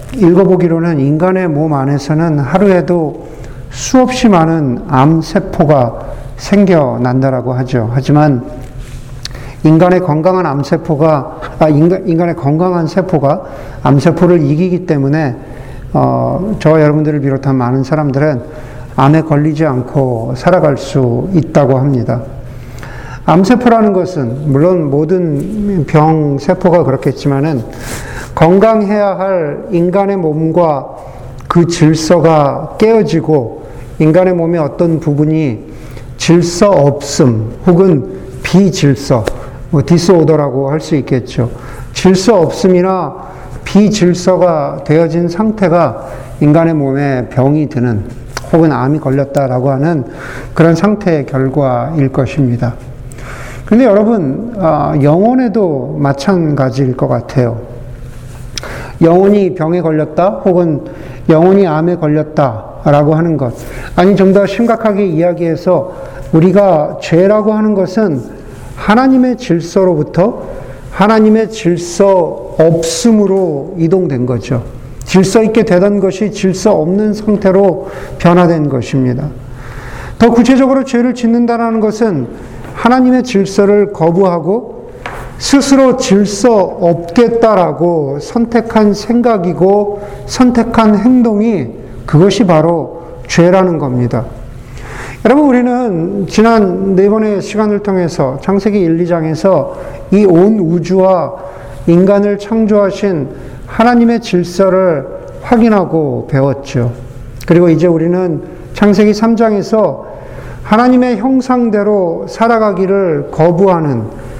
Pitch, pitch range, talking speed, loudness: 165 Hz, 135-195 Hz, 245 characters per minute, -10 LUFS